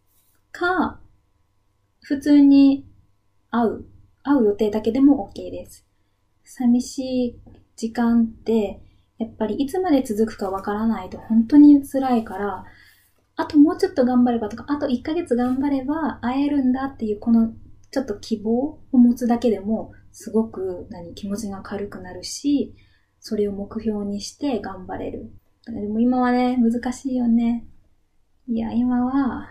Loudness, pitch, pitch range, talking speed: -21 LUFS, 230 Hz, 205-265 Hz, 275 characters per minute